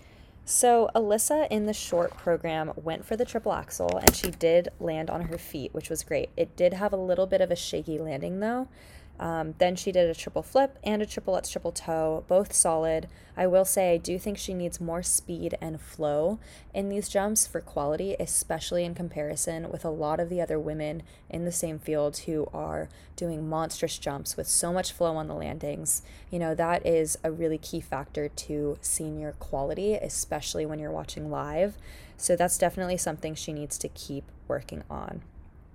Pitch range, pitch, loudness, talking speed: 155-190 Hz, 170 Hz, -28 LUFS, 195 wpm